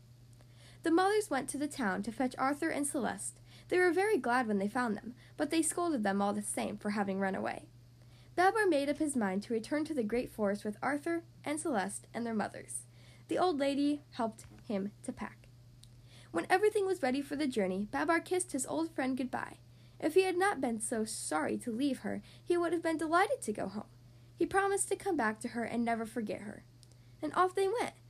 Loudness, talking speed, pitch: -34 LUFS, 215 wpm, 245 Hz